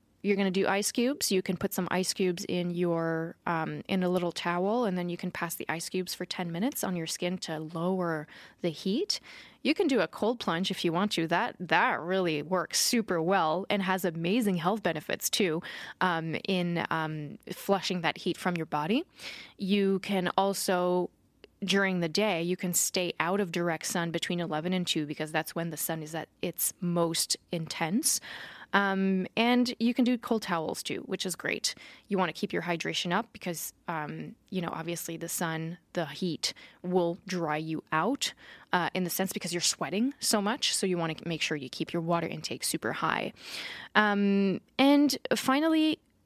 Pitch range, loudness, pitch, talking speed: 170-200 Hz, -30 LUFS, 180 Hz, 195 wpm